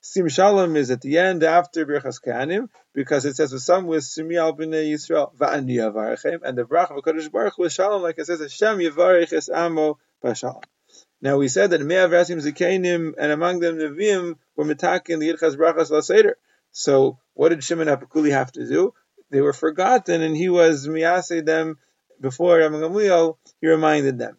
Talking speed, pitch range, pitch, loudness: 170 wpm, 150-175 Hz, 160 Hz, -20 LUFS